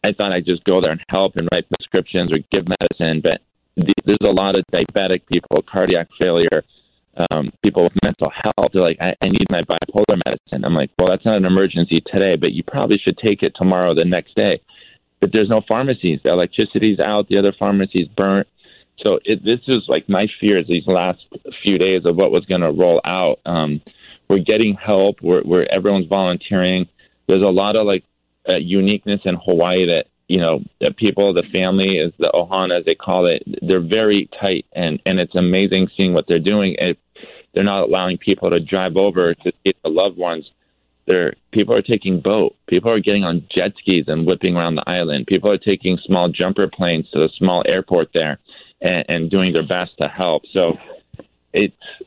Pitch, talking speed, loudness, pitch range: 95 Hz, 200 wpm, -17 LUFS, 90-100 Hz